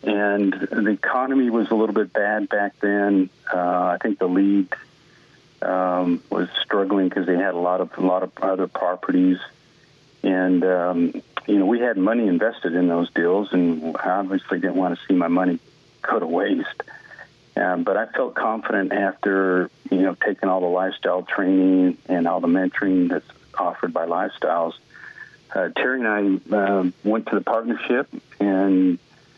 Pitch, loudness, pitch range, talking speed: 95 Hz, -21 LUFS, 90-100 Hz, 170 wpm